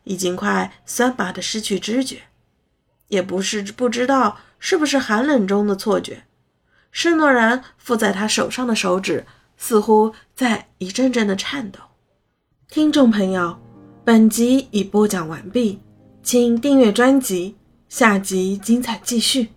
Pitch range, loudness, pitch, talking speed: 195-250 Hz, -18 LUFS, 220 Hz, 205 characters per minute